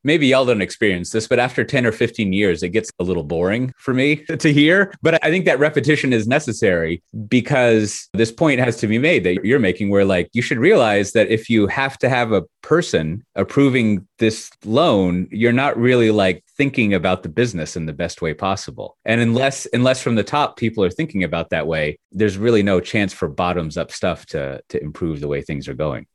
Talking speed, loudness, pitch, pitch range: 215 wpm, -18 LUFS, 110 Hz, 90-130 Hz